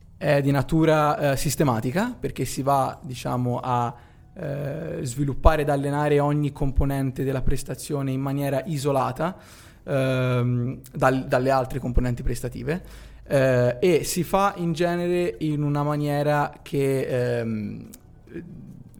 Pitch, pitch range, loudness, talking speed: 140 Hz, 130-150 Hz, -24 LUFS, 120 wpm